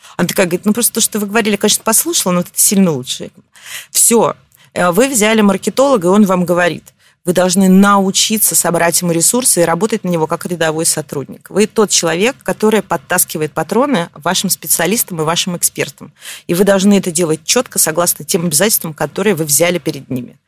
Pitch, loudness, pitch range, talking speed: 180 Hz, -12 LUFS, 170-210 Hz, 180 wpm